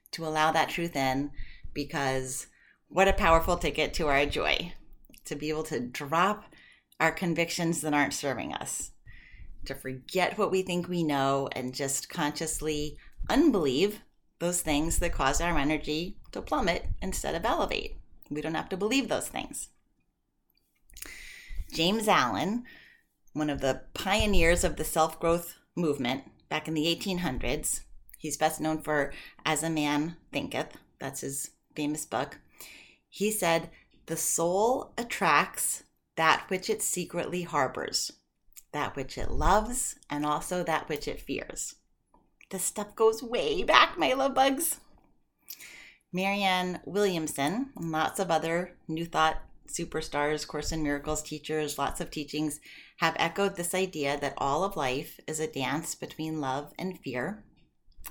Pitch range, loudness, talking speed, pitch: 150-180 Hz, -29 LUFS, 145 wpm, 160 Hz